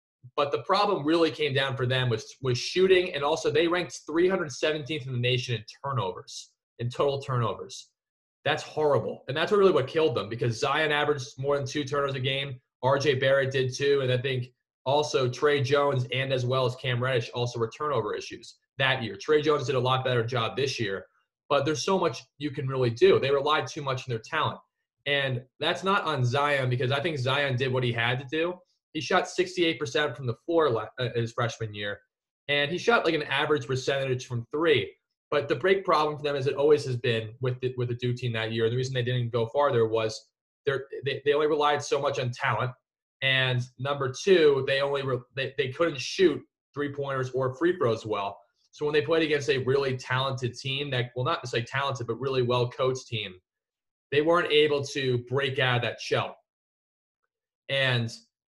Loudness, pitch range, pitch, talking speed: -27 LUFS, 125-150 Hz, 135 Hz, 205 wpm